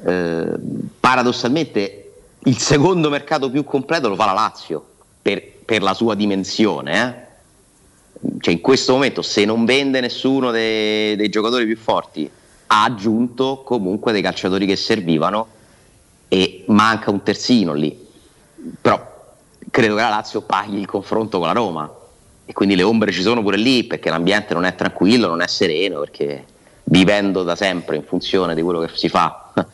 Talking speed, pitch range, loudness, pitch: 160 wpm, 95-125 Hz, -18 LUFS, 105 Hz